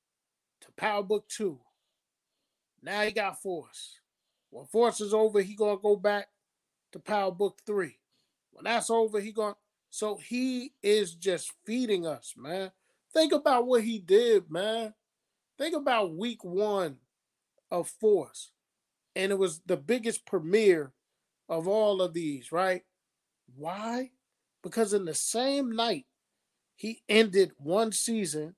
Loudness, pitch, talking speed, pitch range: -29 LUFS, 205 Hz, 135 wpm, 185-225 Hz